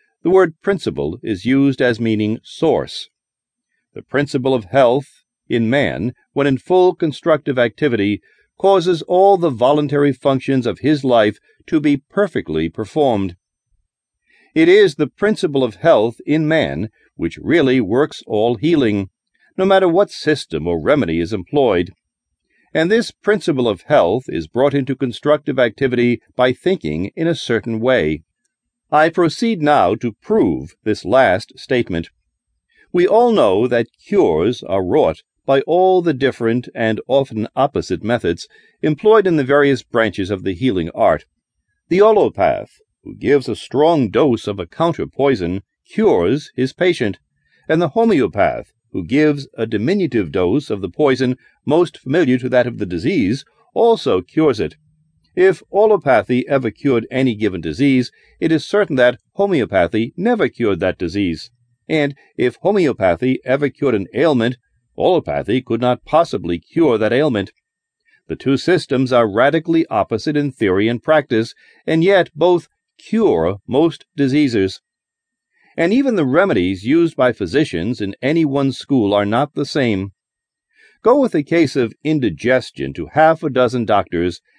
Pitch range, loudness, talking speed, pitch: 115-170 Hz, -16 LUFS, 145 wpm, 140 Hz